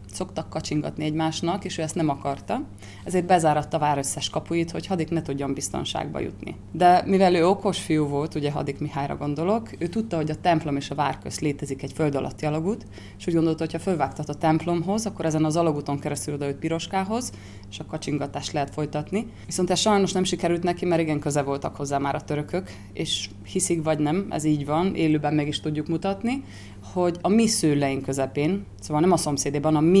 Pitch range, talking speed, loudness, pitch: 145-175 Hz, 200 wpm, -25 LUFS, 155 Hz